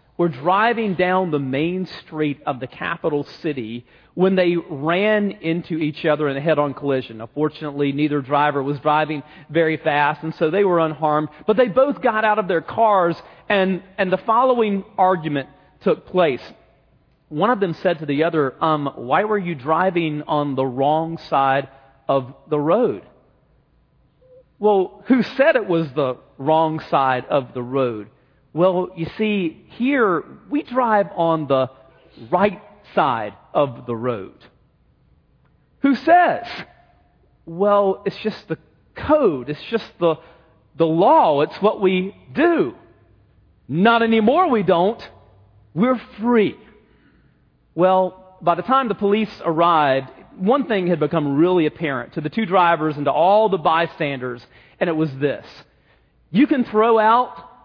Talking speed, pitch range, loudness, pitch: 150 wpm, 145-205 Hz, -19 LUFS, 165 Hz